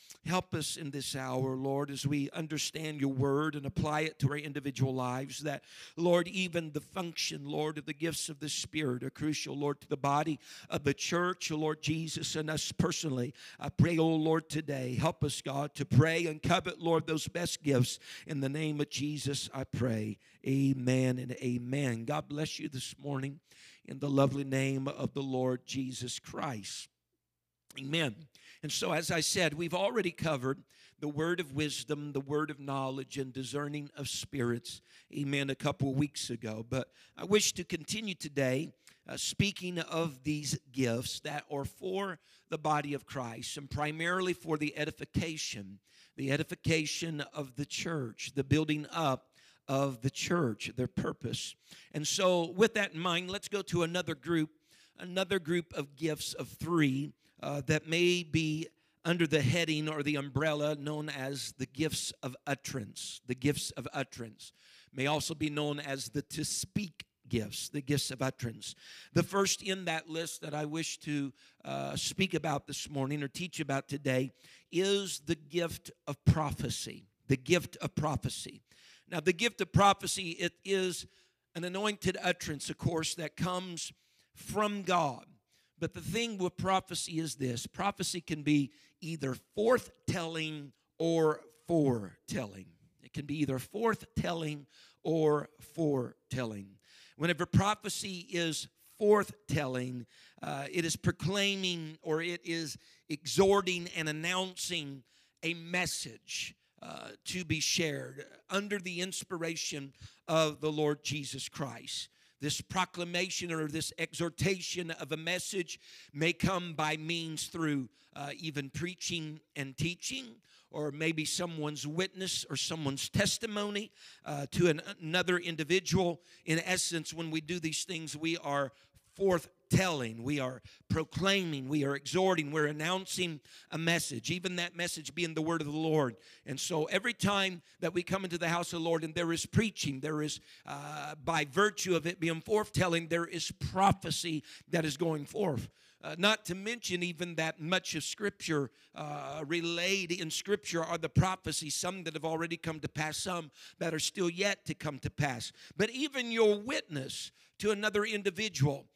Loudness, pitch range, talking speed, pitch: -34 LUFS, 140-175 Hz, 160 wpm, 155 Hz